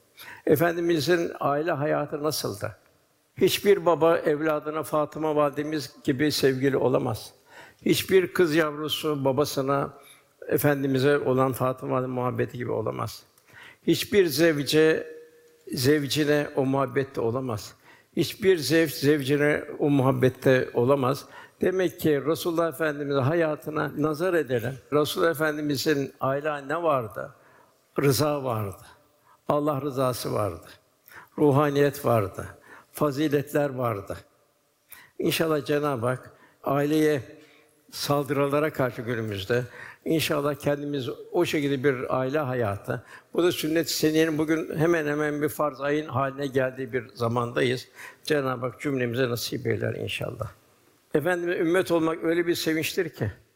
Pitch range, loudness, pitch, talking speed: 135-155 Hz, -25 LUFS, 145 Hz, 110 wpm